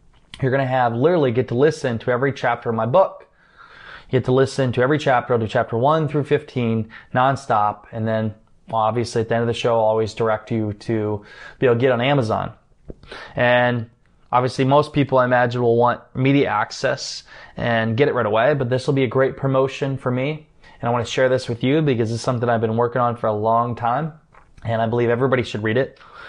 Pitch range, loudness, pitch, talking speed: 115-135 Hz, -20 LUFS, 120 Hz, 225 wpm